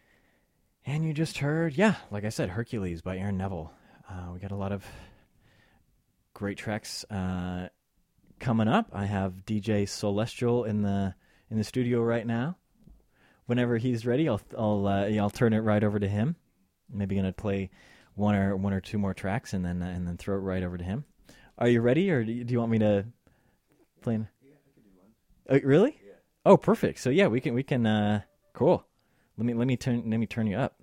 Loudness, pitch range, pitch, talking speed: -28 LUFS, 95-120 Hz, 105 Hz, 200 wpm